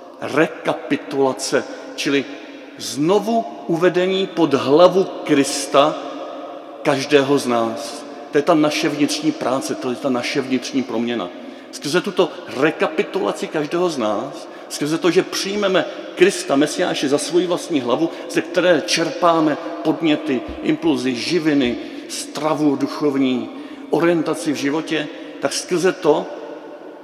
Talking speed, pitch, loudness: 115 wpm, 165 Hz, -19 LUFS